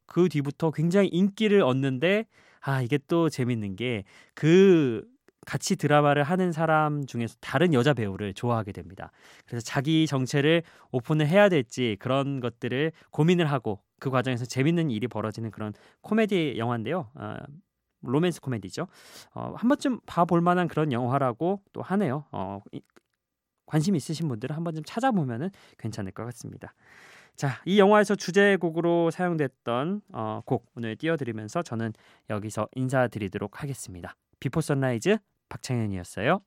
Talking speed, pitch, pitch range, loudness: 335 characters per minute, 140 Hz, 120-170 Hz, -26 LUFS